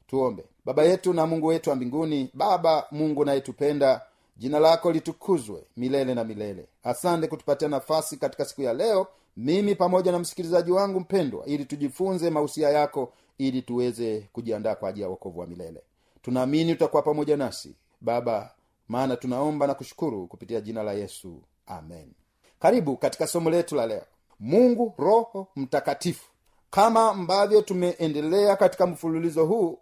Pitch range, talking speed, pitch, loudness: 130-180 Hz, 145 wpm, 155 Hz, -25 LUFS